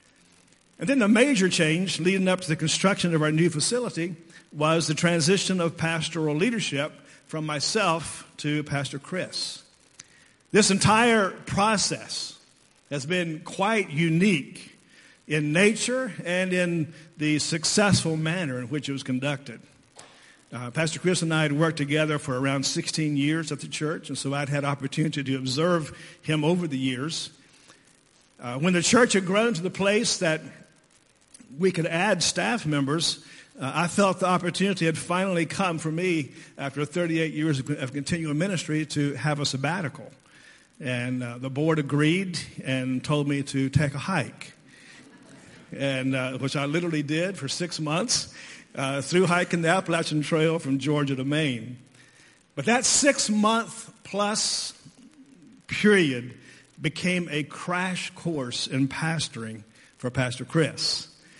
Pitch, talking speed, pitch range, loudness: 160 Hz, 145 wpm, 145-180 Hz, -25 LUFS